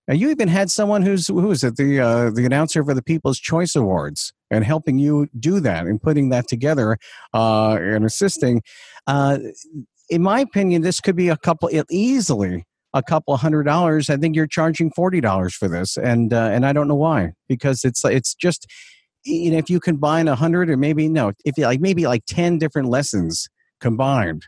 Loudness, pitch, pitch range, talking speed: -19 LUFS, 145 Hz, 120-165 Hz, 200 wpm